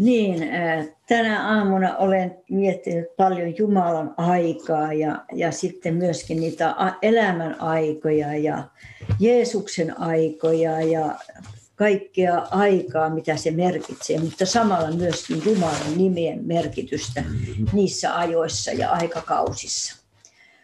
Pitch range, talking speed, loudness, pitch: 160-190 Hz, 100 wpm, -22 LUFS, 170 Hz